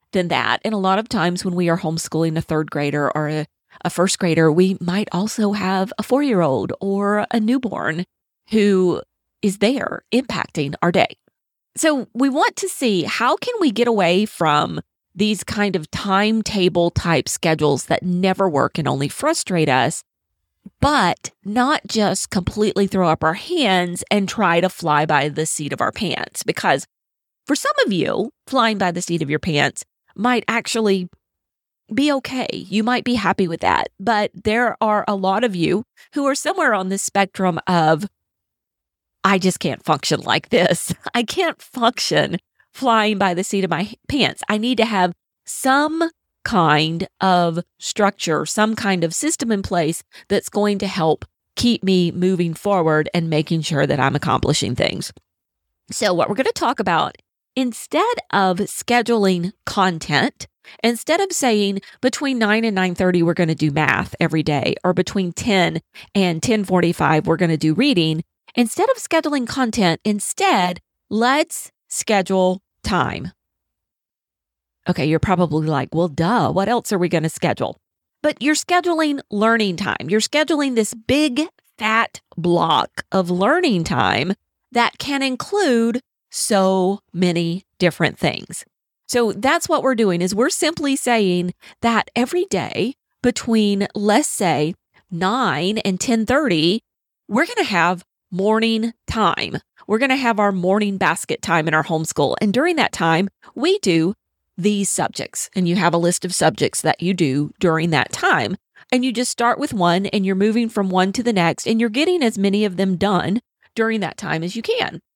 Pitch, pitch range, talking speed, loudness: 195 Hz, 175-235 Hz, 165 wpm, -19 LUFS